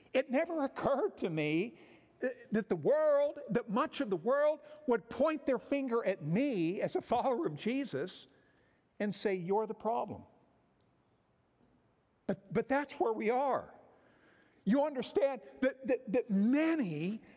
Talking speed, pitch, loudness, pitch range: 140 wpm, 250 Hz, -34 LUFS, 205-285 Hz